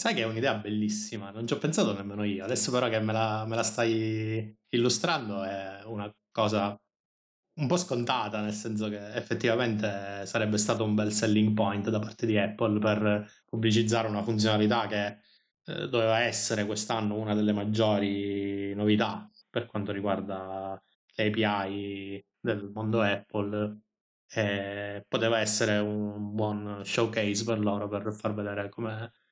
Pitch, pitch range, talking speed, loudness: 105 Hz, 100-110 Hz, 145 wpm, -29 LUFS